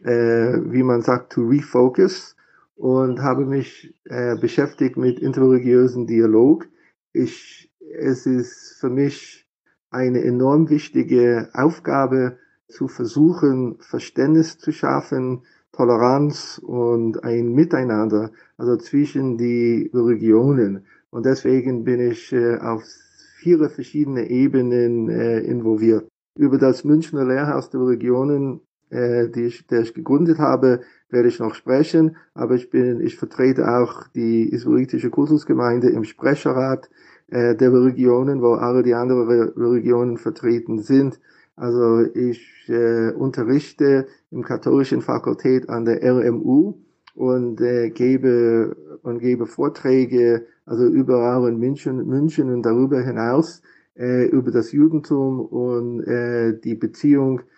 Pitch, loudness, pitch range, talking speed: 125 Hz, -19 LUFS, 120-135 Hz, 120 wpm